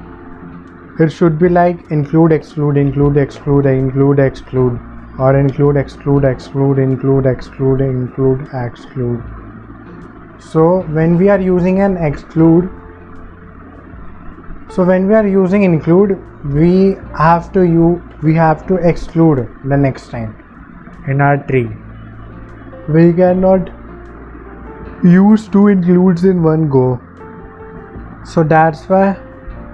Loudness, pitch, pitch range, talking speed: -13 LUFS, 140 Hz, 115-170 Hz, 115 wpm